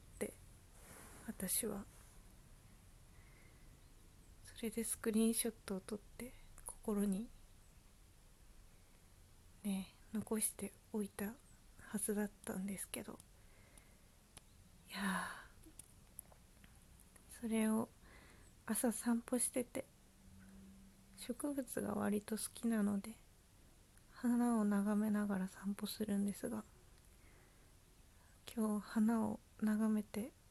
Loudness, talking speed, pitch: -41 LUFS, 160 characters per minute, 200 Hz